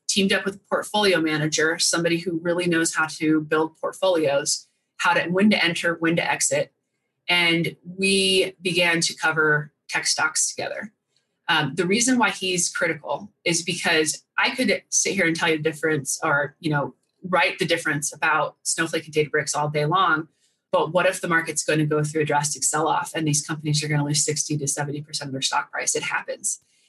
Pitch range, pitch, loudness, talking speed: 150-180 Hz, 165 Hz, -22 LUFS, 190 wpm